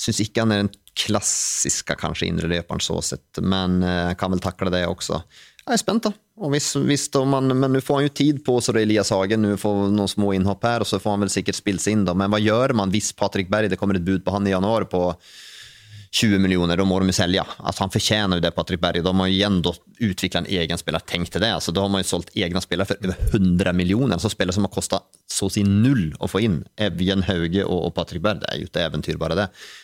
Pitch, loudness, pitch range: 100 Hz, -21 LUFS, 95-110 Hz